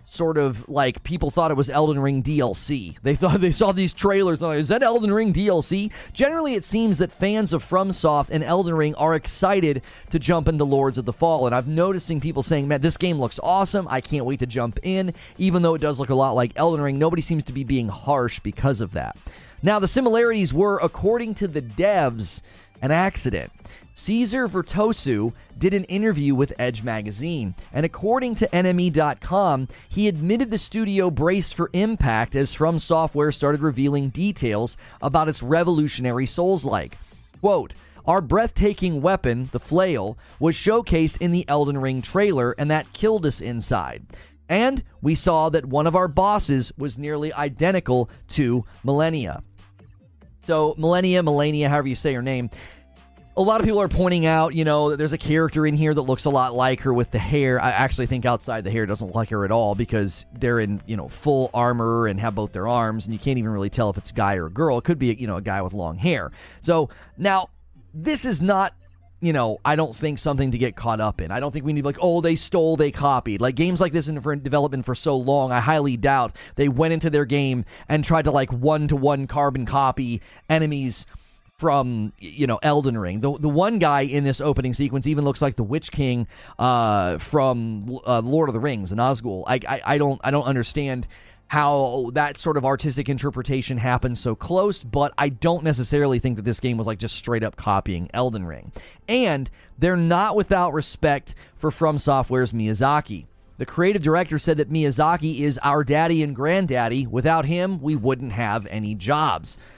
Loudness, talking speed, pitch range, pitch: -22 LUFS, 200 wpm, 120-165 Hz, 145 Hz